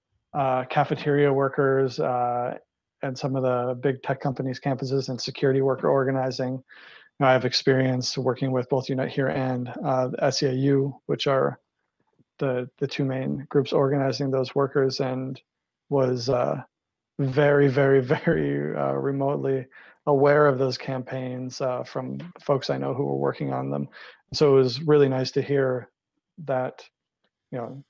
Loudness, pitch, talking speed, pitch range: -24 LUFS, 135 Hz, 155 wpm, 130-140 Hz